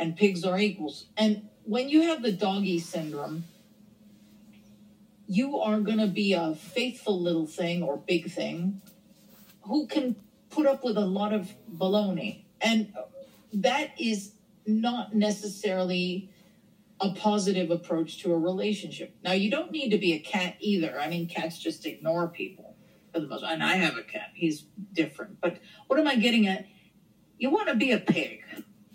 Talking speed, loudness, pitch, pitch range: 165 wpm, -28 LUFS, 200 Hz, 180-215 Hz